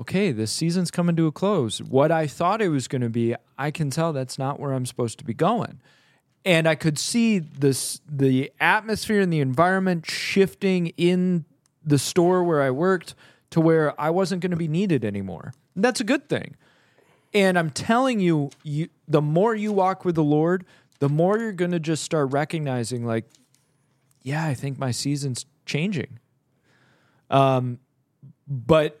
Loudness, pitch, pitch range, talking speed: -23 LUFS, 150 Hz, 135-180 Hz, 180 wpm